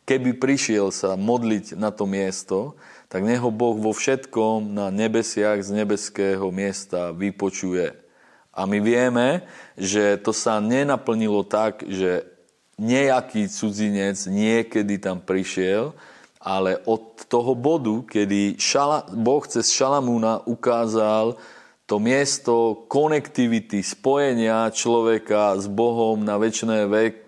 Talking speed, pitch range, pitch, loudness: 110 wpm, 100-120 Hz, 110 Hz, -22 LUFS